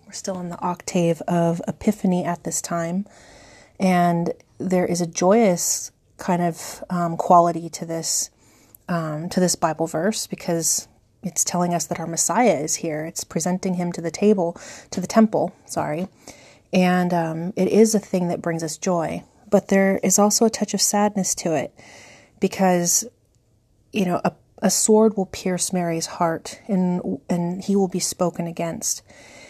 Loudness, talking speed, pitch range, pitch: -21 LUFS, 165 wpm, 170-195 Hz, 180 Hz